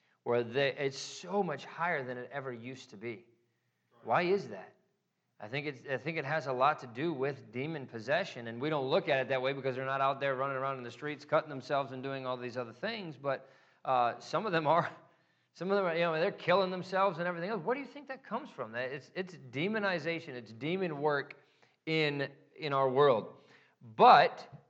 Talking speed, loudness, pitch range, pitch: 220 wpm, -33 LUFS, 130-170 Hz, 140 Hz